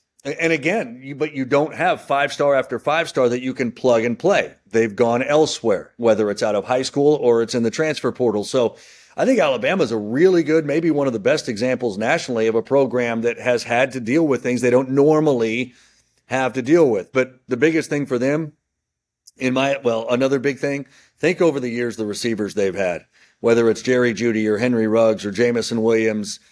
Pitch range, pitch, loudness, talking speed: 115-145 Hz, 125 Hz, -19 LUFS, 215 wpm